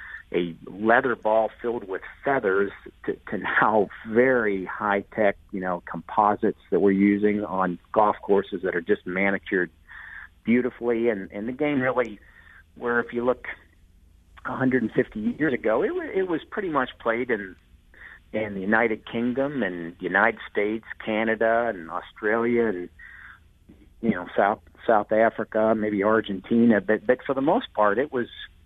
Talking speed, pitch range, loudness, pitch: 145 wpm, 95-120 Hz, -24 LUFS, 110 Hz